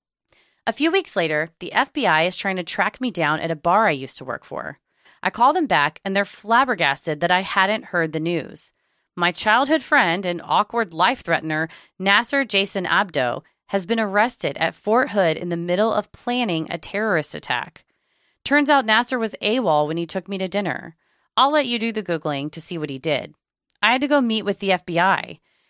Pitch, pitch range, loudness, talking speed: 195 Hz, 165-225 Hz, -21 LUFS, 205 wpm